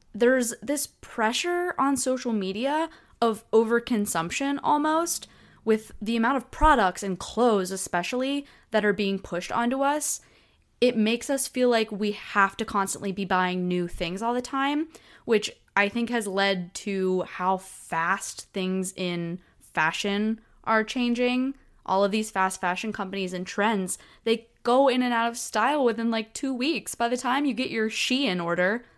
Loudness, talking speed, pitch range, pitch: -26 LUFS, 165 wpm, 195-250 Hz, 225 Hz